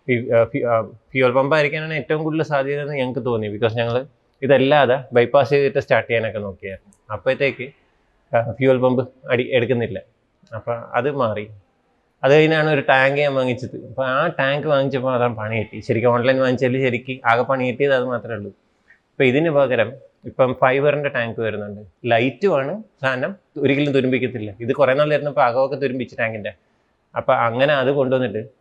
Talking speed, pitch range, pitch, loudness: 145 wpm, 115-140 Hz, 130 Hz, -19 LUFS